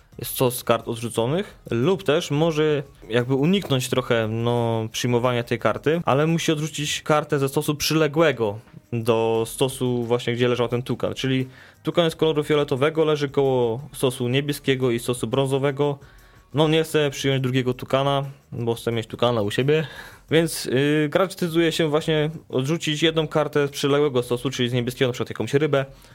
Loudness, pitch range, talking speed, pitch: -22 LUFS, 120-150 Hz, 160 wpm, 135 Hz